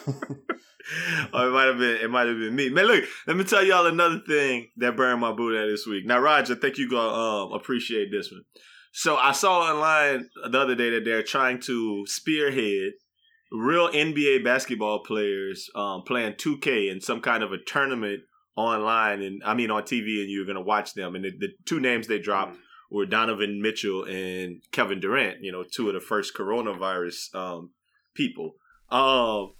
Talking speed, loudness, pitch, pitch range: 190 wpm, -25 LUFS, 115 Hz, 100-140 Hz